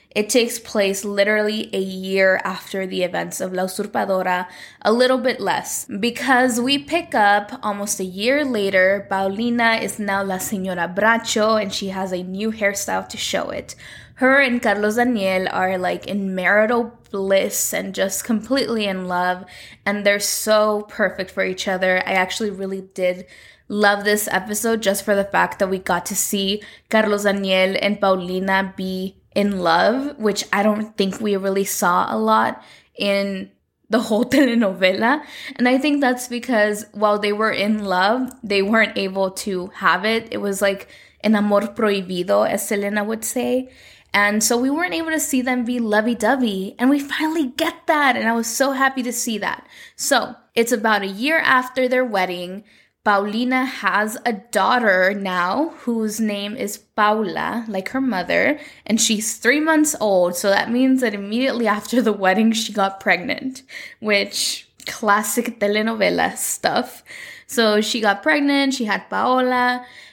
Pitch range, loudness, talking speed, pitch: 195-245 Hz, -19 LUFS, 165 wpm, 210 Hz